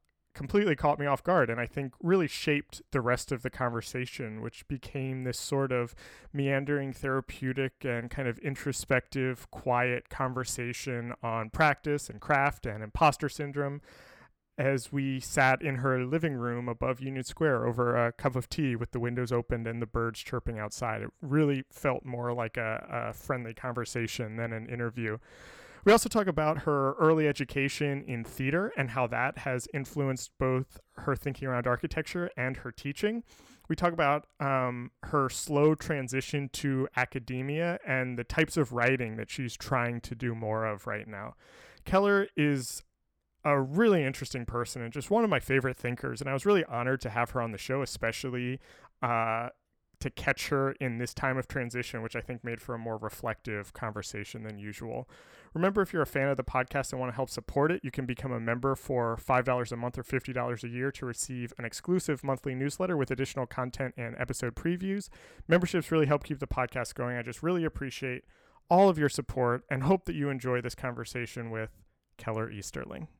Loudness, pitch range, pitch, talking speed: -31 LUFS, 120-145 Hz, 130 Hz, 185 wpm